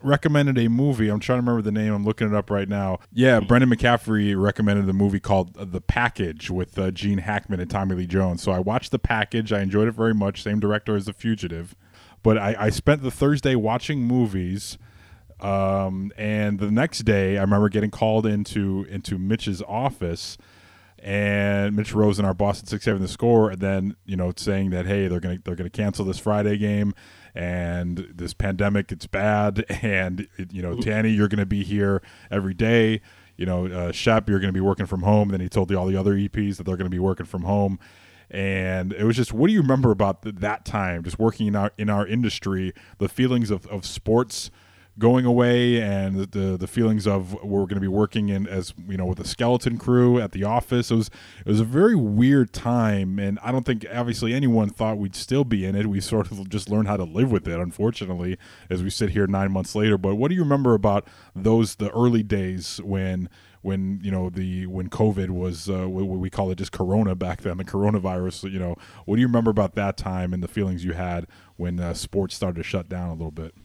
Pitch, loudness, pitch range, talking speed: 100 Hz, -23 LUFS, 95-110 Hz, 225 wpm